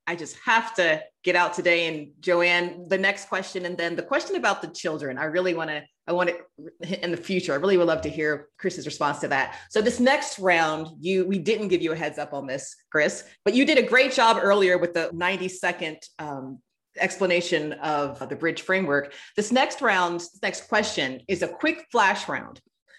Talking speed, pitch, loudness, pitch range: 210 wpm, 175 Hz, -24 LUFS, 160-195 Hz